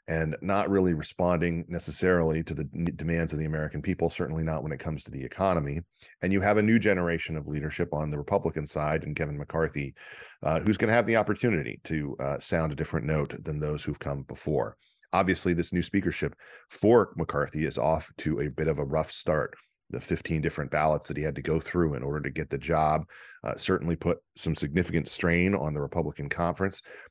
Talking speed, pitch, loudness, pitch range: 205 wpm, 80 Hz, -29 LUFS, 75-90 Hz